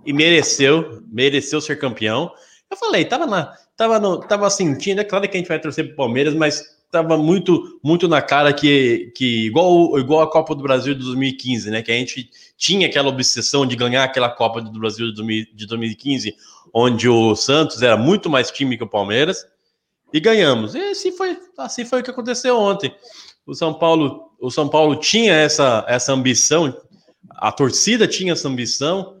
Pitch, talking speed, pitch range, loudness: 150 Hz, 185 wpm, 125-185 Hz, -17 LUFS